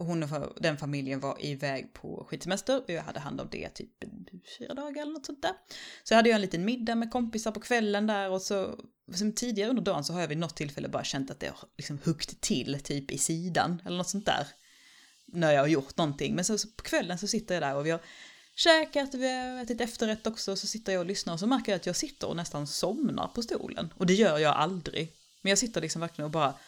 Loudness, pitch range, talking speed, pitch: -30 LUFS, 160-230 Hz, 255 wpm, 190 Hz